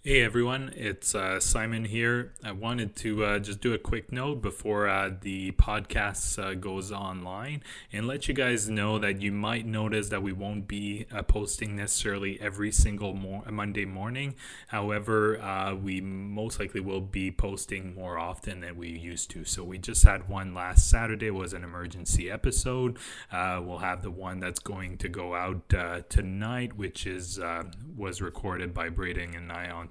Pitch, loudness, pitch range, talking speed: 100 Hz, -30 LUFS, 90-110 Hz, 185 wpm